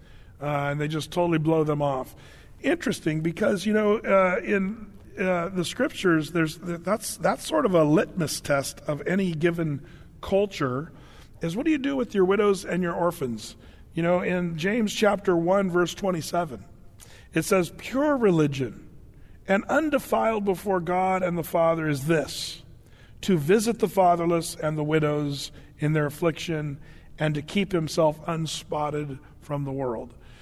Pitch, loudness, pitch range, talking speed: 170 Hz, -25 LUFS, 150-190 Hz, 155 wpm